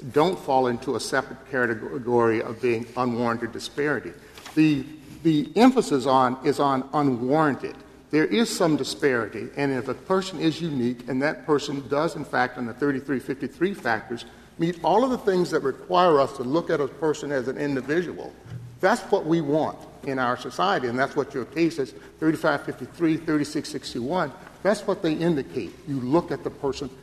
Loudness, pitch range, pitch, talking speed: -25 LUFS, 130-165 Hz, 145 Hz, 170 wpm